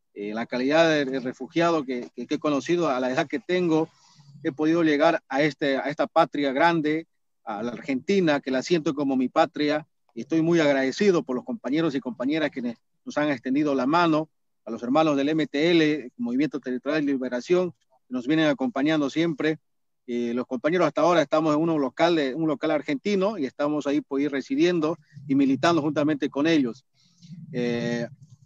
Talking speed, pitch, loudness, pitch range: 190 wpm, 150 Hz, -24 LUFS, 135-165 Hz